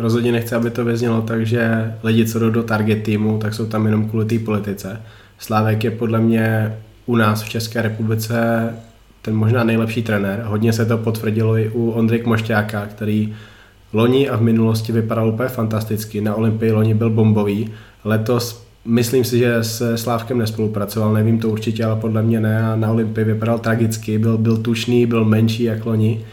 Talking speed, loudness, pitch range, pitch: 180 wpm, -18 LUFS, 110-115 Hz, 110 Hz